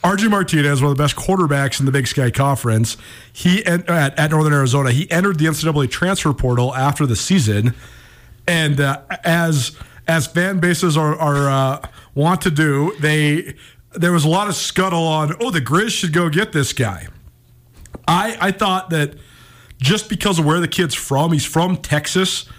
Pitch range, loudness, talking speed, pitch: 135-175 Hz, -17 LUFS, 180 wpm, 150 Hz